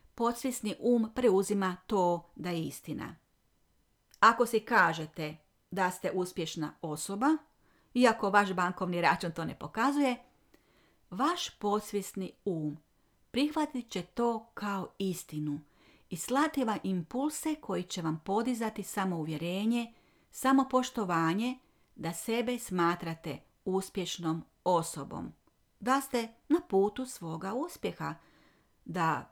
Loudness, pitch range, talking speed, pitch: -32 LUFS, 170-240 Hz, 105 wpm, 195 Hz